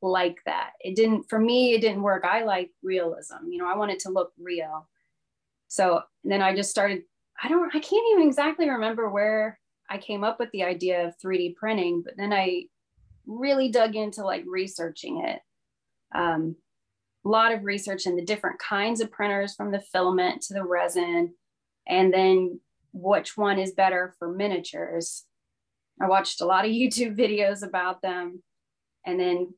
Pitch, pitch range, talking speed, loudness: 195 Hz, 180-220 Hz, 180 wpm, -26 LUFS